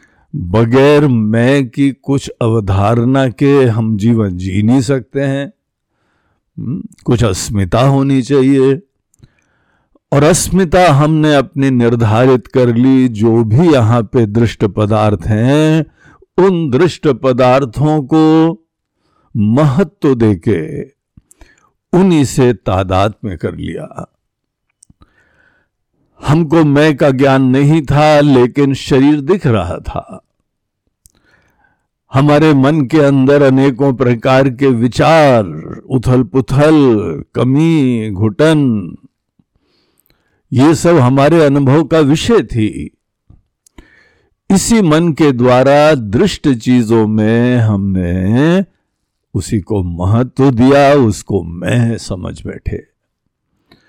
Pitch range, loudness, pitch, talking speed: 115-145 Hz, -11 LUFS, 135 Hz, 100 wpm